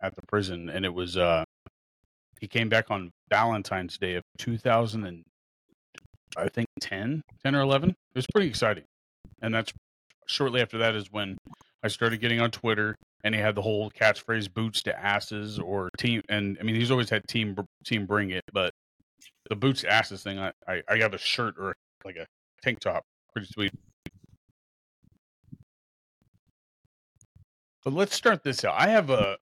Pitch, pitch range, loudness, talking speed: 105 Hz, 95-115 Hz, -27 LUFS, 175 wpm